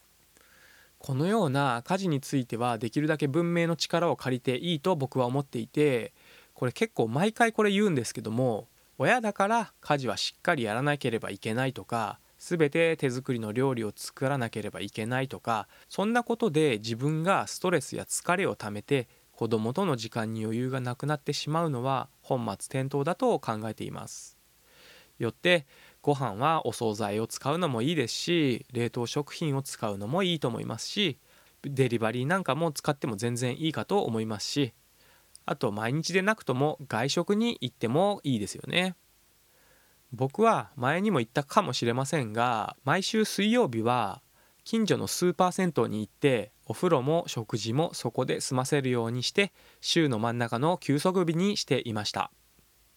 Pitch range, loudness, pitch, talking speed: 120-170 Hz, -29 LUFS, 135 Hz, 340 characters per minute